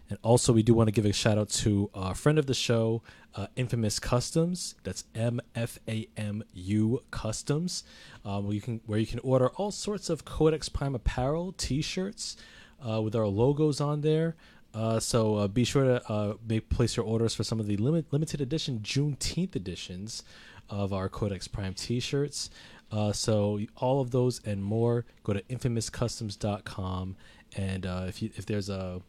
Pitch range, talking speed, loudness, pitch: 105-130 Hz, 175 wpm, -30 LUFS, 115 Hz